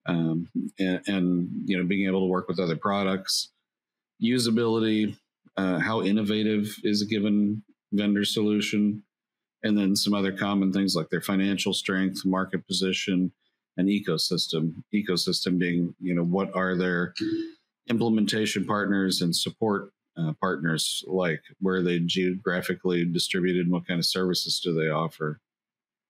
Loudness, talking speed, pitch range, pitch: -26 LUFS, 145 wpm, 90-105 Hz, 95 Hz